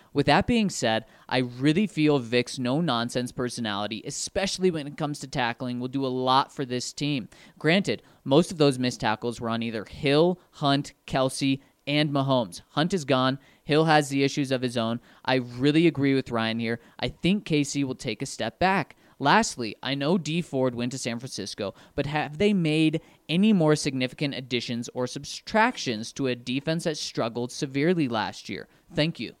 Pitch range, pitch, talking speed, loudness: 125-155 Hz, 140 Hz, 185 wpm, -26 LUFS